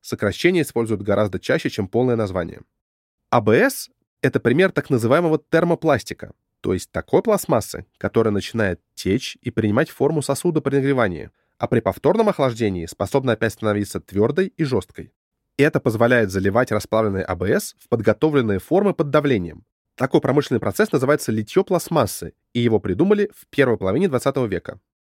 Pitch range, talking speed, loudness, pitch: 105-150 Hz, 145 wpm, -20 LUFS, 120 Hz